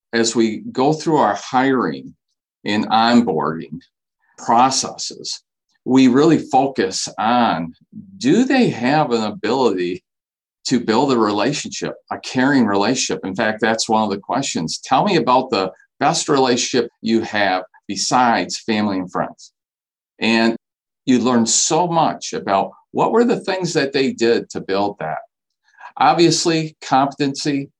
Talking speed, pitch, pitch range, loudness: 135 wpm, 125 Hz, 115-160 Hz, -18 LUFS